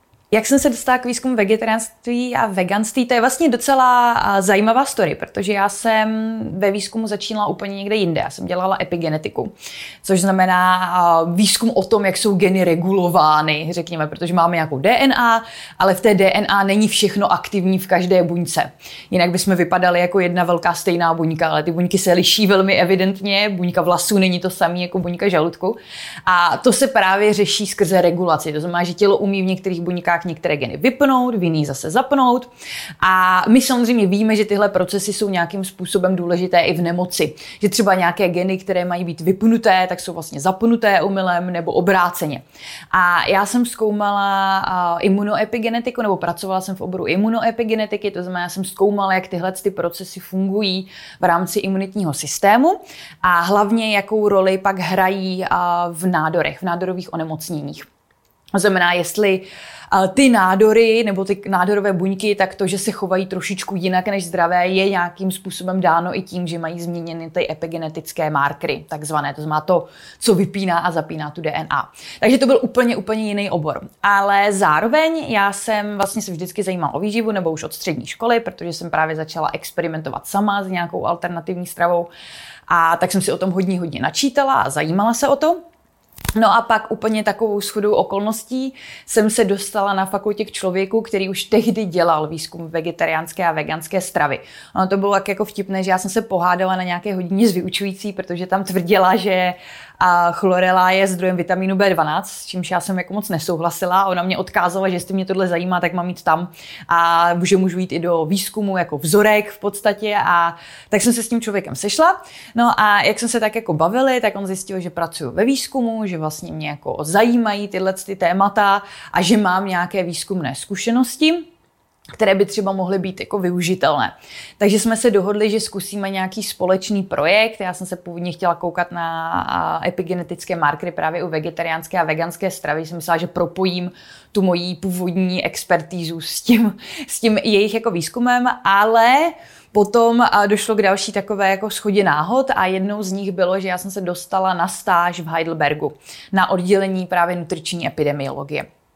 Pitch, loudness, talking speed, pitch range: 190 Hz, -18 LUFS, 175 wpm, 175-210 Hz